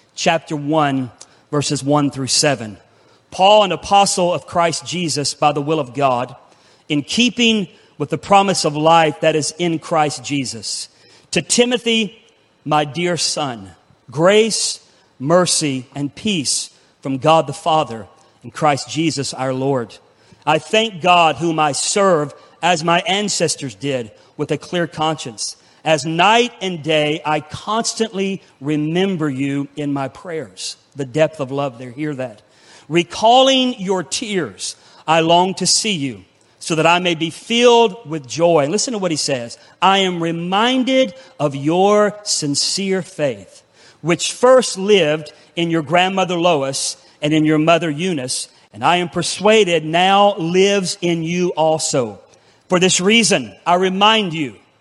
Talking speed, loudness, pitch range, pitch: 145 wpm, -17 LUFS, 145-185 Hz, 160 Hz